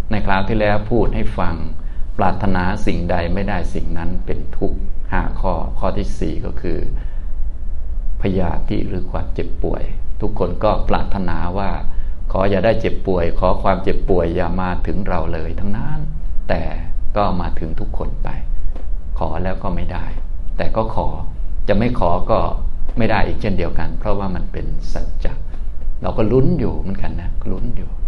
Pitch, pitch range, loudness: 85 Hz, 75-100 Hz, -22 LUFS